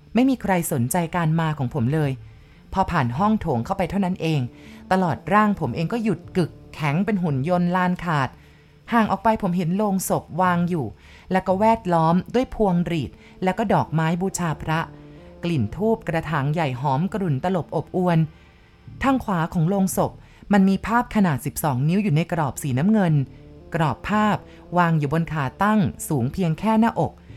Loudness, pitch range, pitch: -22 LUFS, 145-190 Hz, 170 Hz